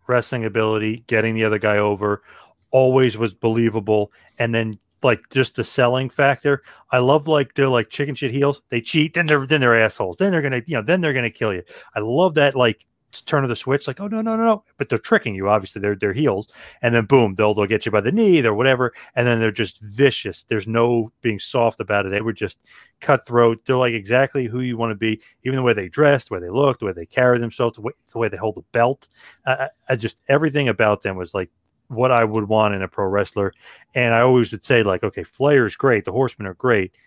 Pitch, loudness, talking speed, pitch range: 120 Hz, -19 LUFS, 245 wpm, 110-135 Hz